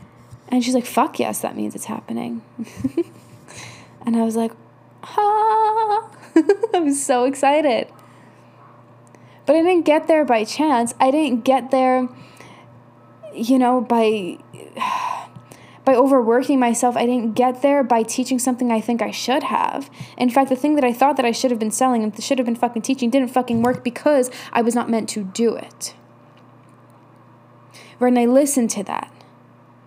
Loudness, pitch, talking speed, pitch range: -19 LUFS, 250 Hz, 165 wpm, 225-275 Hz